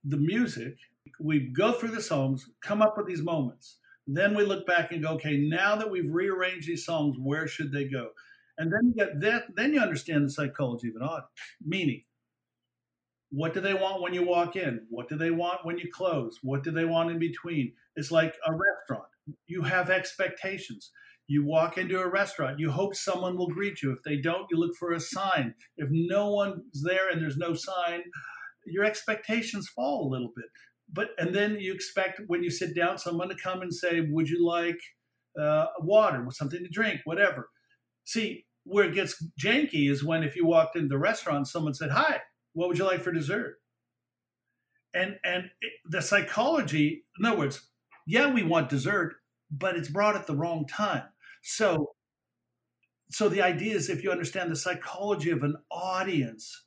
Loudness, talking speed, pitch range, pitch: -29 LUFS, 195 wpm, 155-195 Hz, 170 Hz